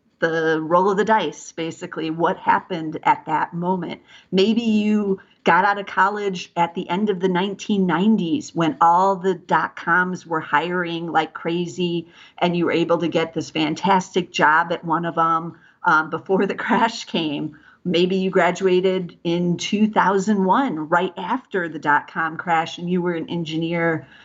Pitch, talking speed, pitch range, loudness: 175 Hz, 165 wpm, 165-190 Hz, -21 LUFS